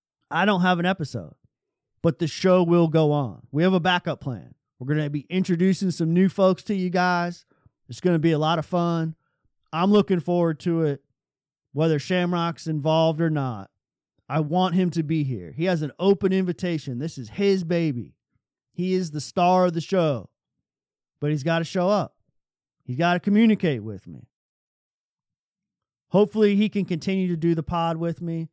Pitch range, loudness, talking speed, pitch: 150-185 Hz, -23 LUFS, 185 wpm, 170 Hz